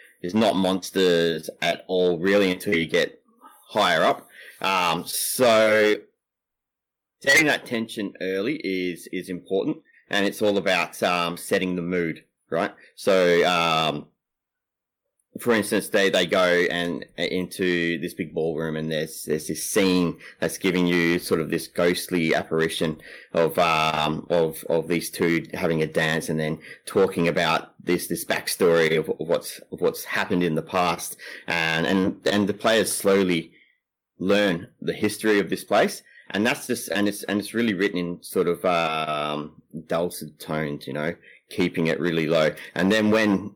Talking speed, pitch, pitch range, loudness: 155 wpm, 90 Hz, 80-100 Hz, -23 LUFS